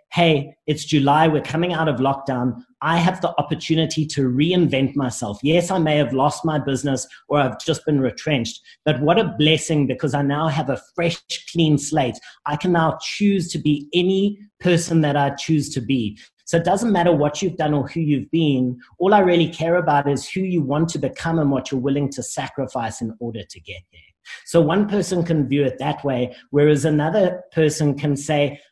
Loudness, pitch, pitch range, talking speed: -20 LUFS, 150 Hz, 135-165 Hz, 205 wpm